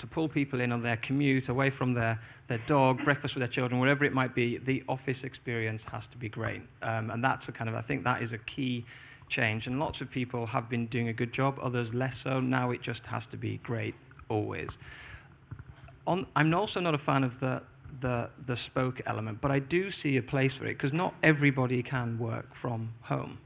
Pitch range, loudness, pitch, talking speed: 120-135 Hz, -31 LUFS, 130 Hz, 220 wpm